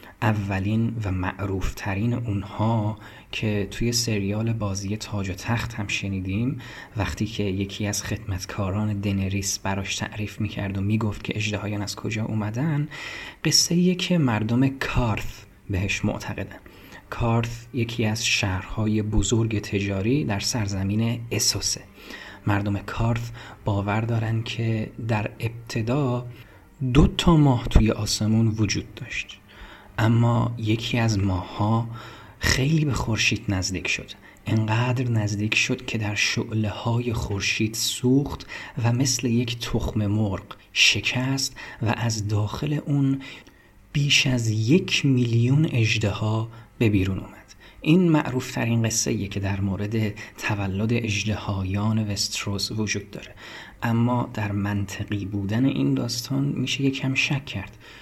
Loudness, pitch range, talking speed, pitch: -24 LUFS, 100-120 Hz, 125 wpm, 110 Hz